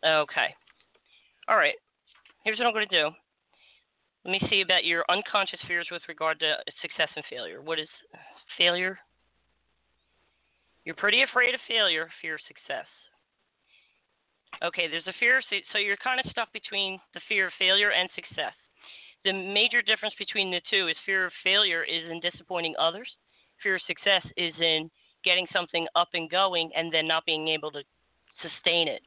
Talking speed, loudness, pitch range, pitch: 165 wpm, -26 LUFS, 165-205 Hz, 180 Hz